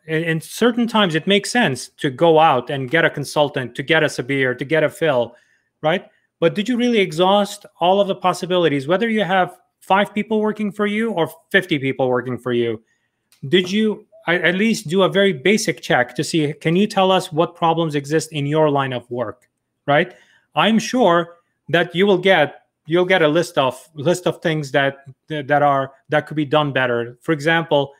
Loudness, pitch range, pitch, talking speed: -18 LUFS, 145-190 Hz, 165 Hz, 200 wpm